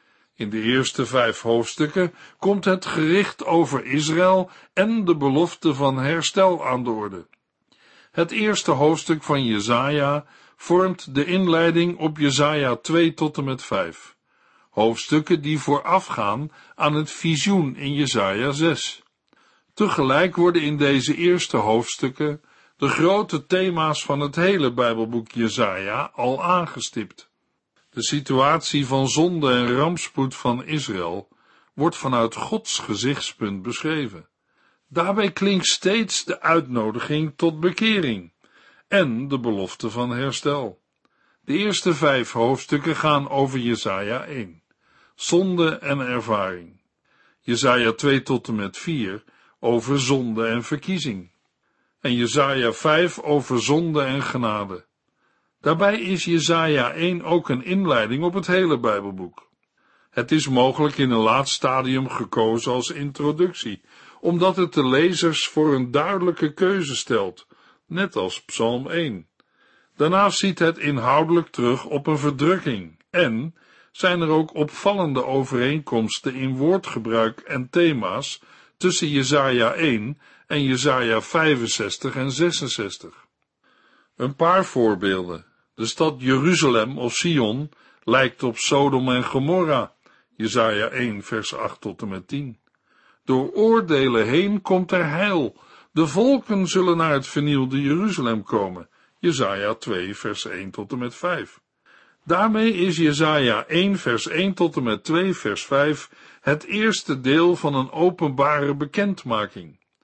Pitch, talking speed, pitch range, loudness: 145 Hz, 125 wpm, 125-170 Hz, -21 LUFS